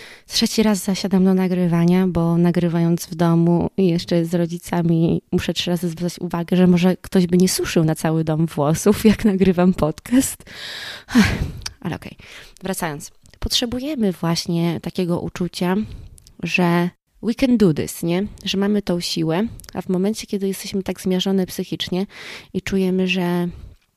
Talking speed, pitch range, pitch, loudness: 150 wpm, 170-195 Hz, 180 Hz, -20 LUFS